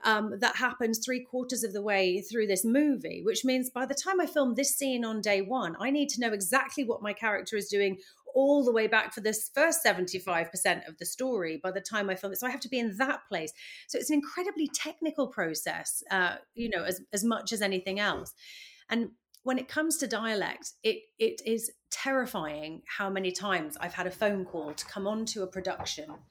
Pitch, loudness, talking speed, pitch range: 225 Hz, -30 LUFS, 220 wpm, 195-270 Hz